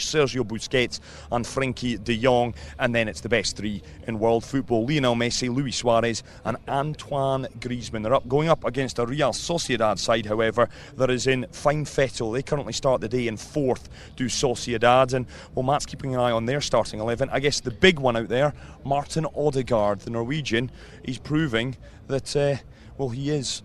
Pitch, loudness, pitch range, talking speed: 125 Hz, -24 LUFS, 115-140 Hz, 190 wpm